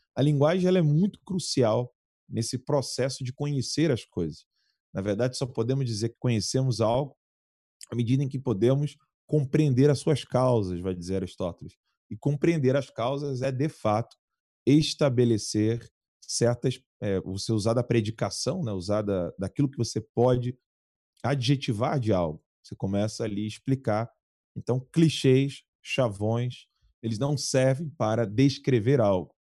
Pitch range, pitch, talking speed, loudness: 110-140 Hz, 125 Hz, 145 wpm, -27 LUFS